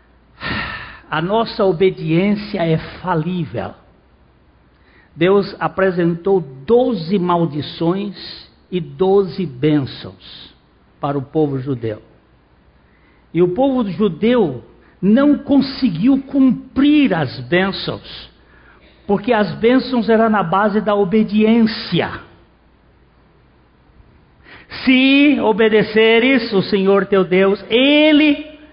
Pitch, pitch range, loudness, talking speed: 195 Hz, 155-230 Hz, -16 LUFS, 85 wpm